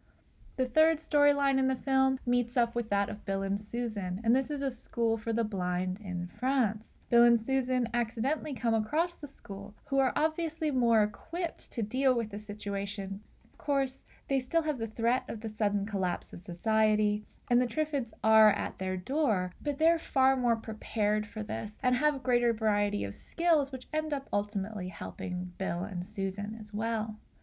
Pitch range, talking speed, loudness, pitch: 205-270 Hz, 190 wpm, -30 LUFS, 230 Hz